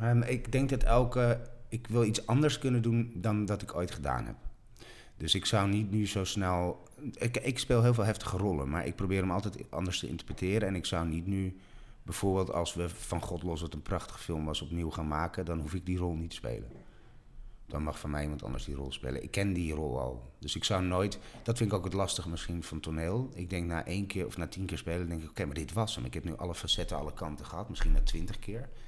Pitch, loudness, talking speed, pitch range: 95 Hz, -33 LUFS, 255 wpm, 80-110 Hz